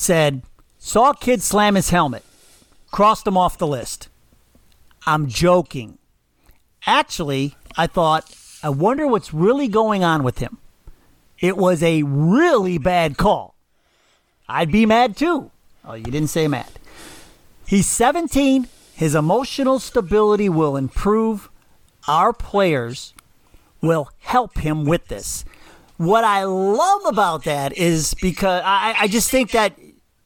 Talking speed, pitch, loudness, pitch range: 130 wpm, 180 Hz, -18 LUFS, 155-220 Hz